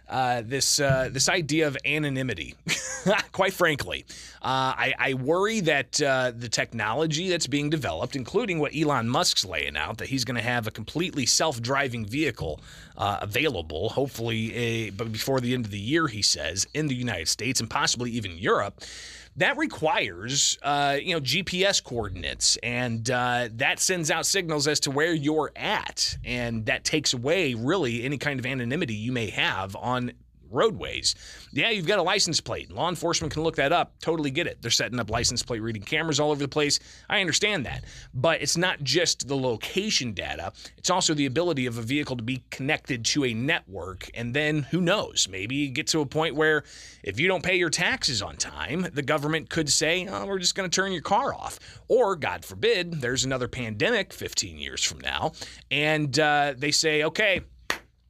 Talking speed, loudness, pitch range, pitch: 190 wpm, -25 LUFS, 120-160 Hz, 140 Hz